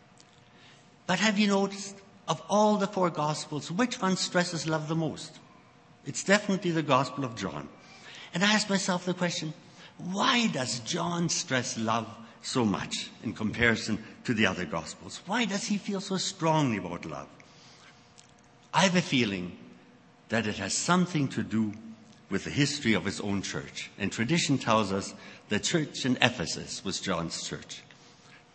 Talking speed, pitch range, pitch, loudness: 160 wpm, 115-190 Hz, 160 Hz, -29 LUFS